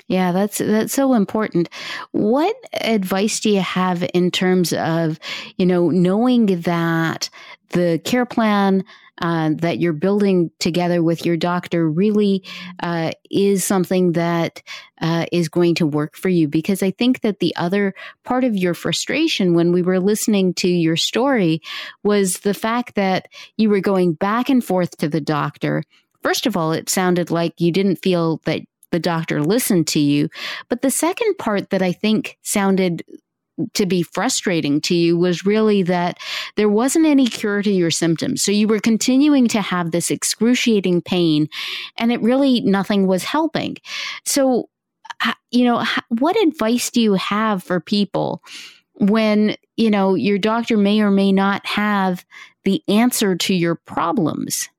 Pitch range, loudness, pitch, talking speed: 175-225 Hz, -18 LUFS, 195 Hz, 160 wpm